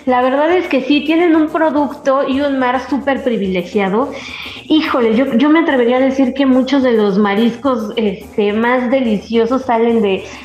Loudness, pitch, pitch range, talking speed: -14 LUFS, 260 Hz, 230-280 Hz, 170 wpm